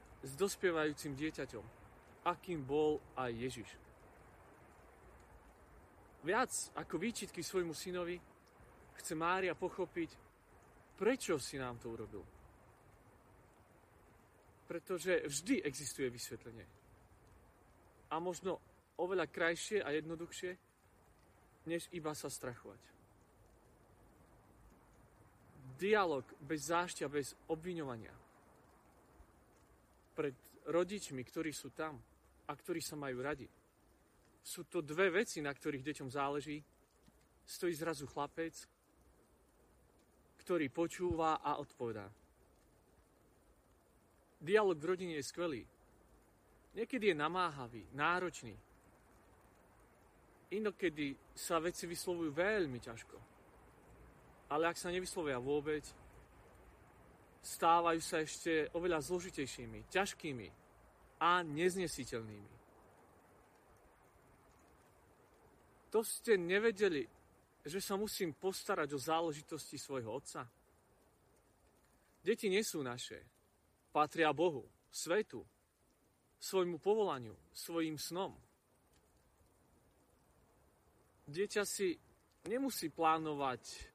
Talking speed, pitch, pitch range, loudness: 85 wpm, 155 Hz, 115-175 Hz, -39 LUFS